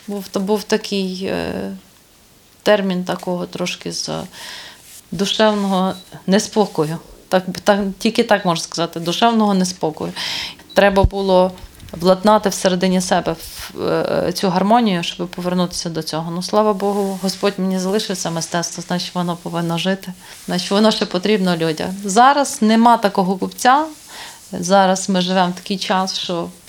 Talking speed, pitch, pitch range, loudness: 125 wpm, 190 Hz, 175-205 Hz, -18 LUFS